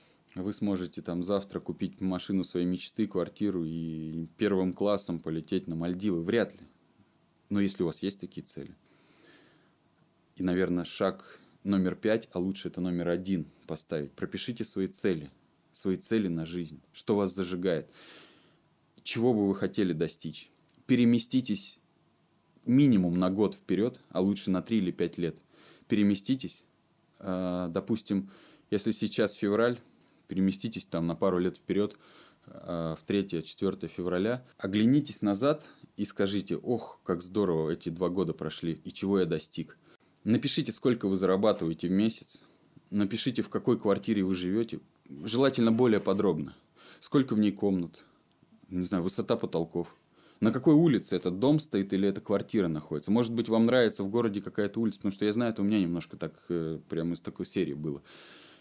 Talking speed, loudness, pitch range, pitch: 150 wpm, -30 LUFS, 90-110 Hz, 95 Hz